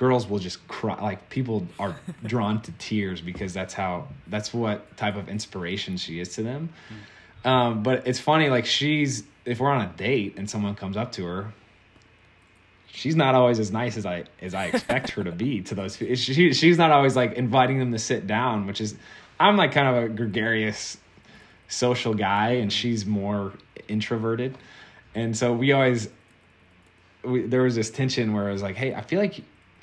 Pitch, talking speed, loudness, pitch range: 110 Hz, 190 wpm, -24 LUFS, 100-125 Hz